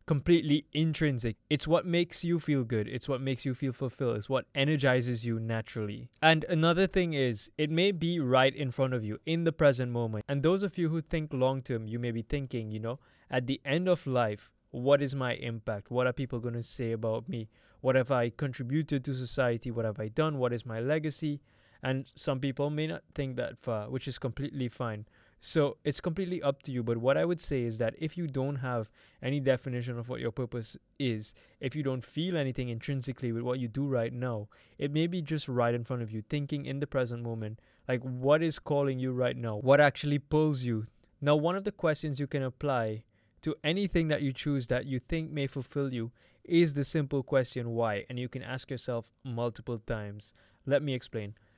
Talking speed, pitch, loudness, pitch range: 220 wpm, 130 Hz, -31 LUFS, 120-145 Hz